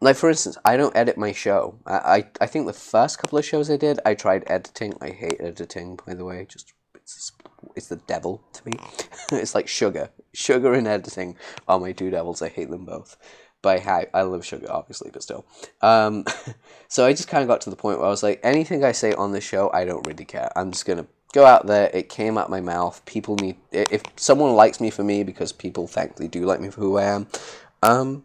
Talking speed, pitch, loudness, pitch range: 235 wpm, 100 Hz, -21 LUFS, 95-110 Hz